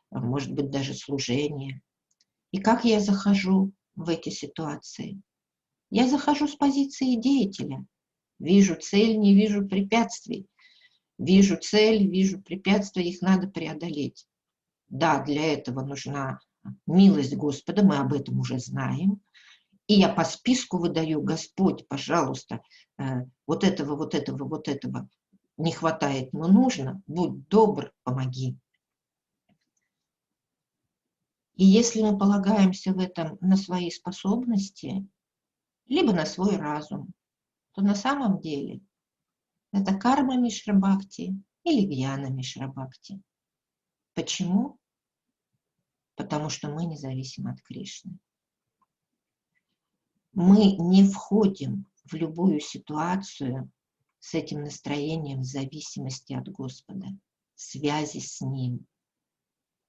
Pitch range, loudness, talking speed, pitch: 145-200 Hz, -25 LUFS, 105 wpm, 180 Hz